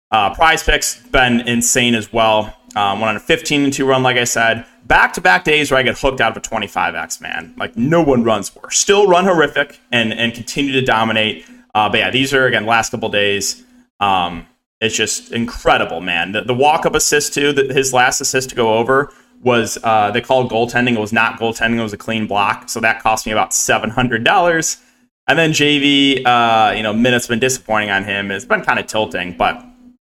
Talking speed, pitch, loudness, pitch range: 220 wpm, 120 Hz, -15 LUFS, 110-135 Hz